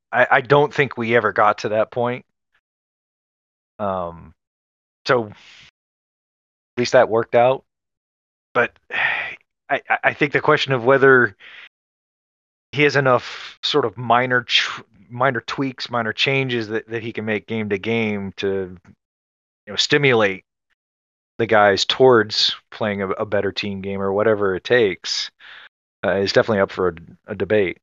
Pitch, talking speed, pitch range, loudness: 110 Hz, 150 wpm, 90-120 Hz, -19 LUFS